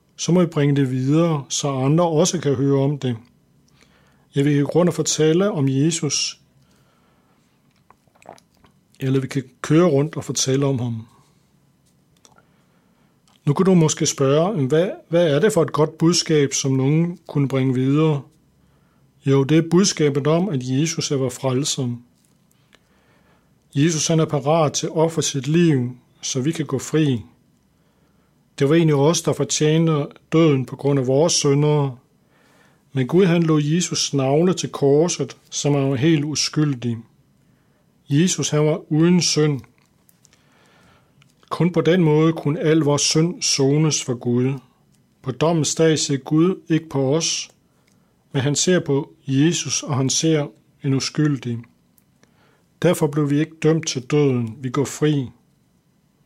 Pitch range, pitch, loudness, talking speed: 135-160 Hz, 150 Hz, -19 LUFS, 150 wpm